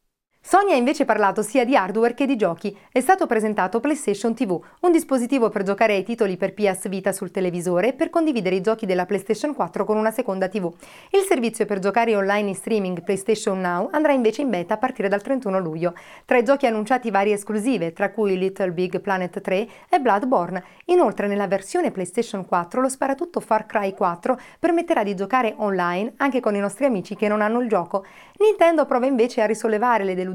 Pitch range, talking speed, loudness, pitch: 195-255 Hz, 200 wpm, -21 LUFS, 215 Hz